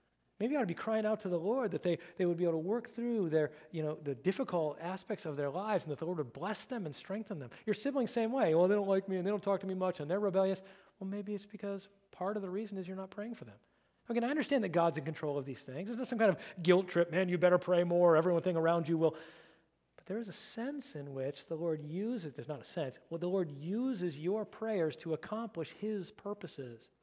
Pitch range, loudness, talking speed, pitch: 160-210 Hz, -35 LUFS, 270 wpm, 185 Hz